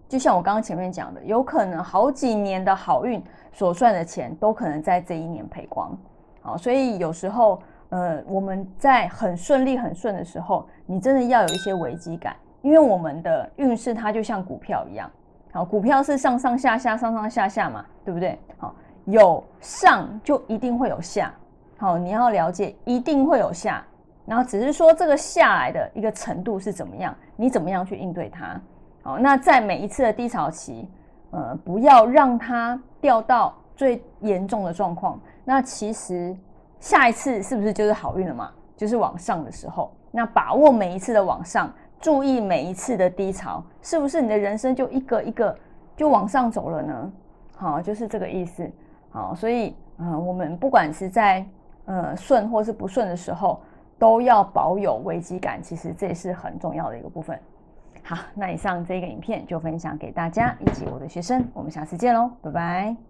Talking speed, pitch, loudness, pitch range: 275 characters per minute, 215 Hz, -22 LUFS, 180-250 Hz